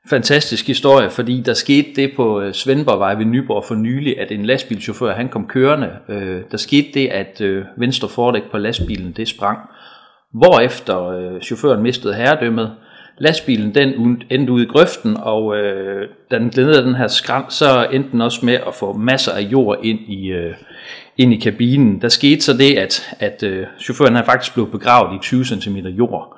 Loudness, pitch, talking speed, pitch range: -15 LUFS, 120 Hz, 165 wpm, 105-135 Hz